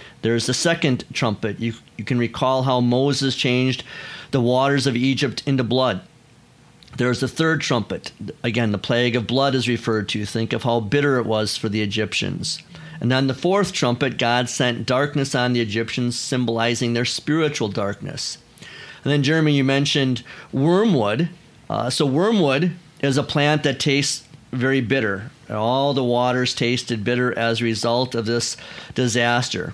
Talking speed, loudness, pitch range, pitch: 160 wpm, -21 LUFS, 120-140 Hz, 125 Hz